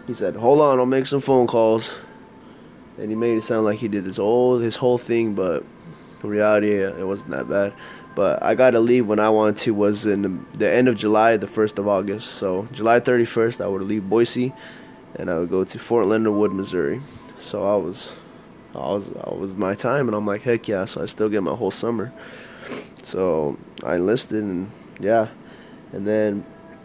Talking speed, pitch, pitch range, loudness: 205 wpm, 110 Hz, 100-120 Hz, -21 LUFS